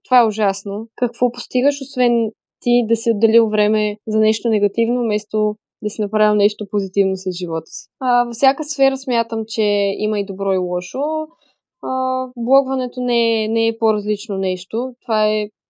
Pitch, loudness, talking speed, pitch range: 225 Hz, -18 LUFS, 165 wpm, 210-245 Hz